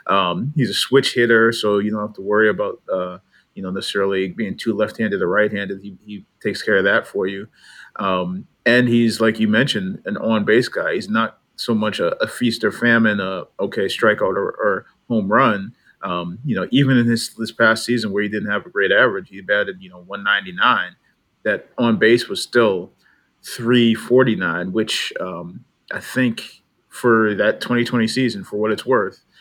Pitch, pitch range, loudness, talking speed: 110 Hz, 100-115 Hz, -19 LUFS, 200 wpm